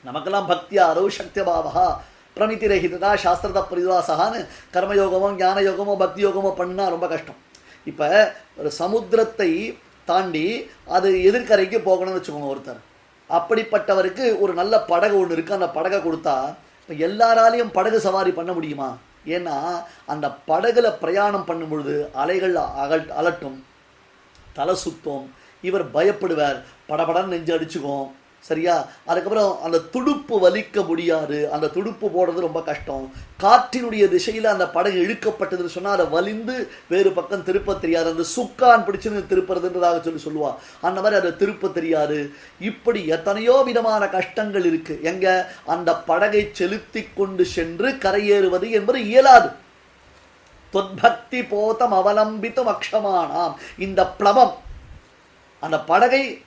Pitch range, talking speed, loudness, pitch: 170-215 Hz, 115 wpm, -20 LUFS, 190 Hz